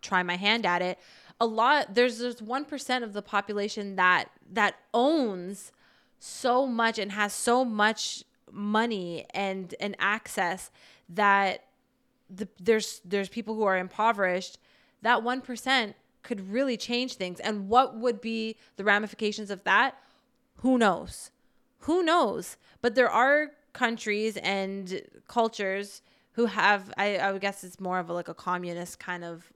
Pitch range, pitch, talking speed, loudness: 195-240 Hz, 210 Hz, 150 wpm, -27 LUFS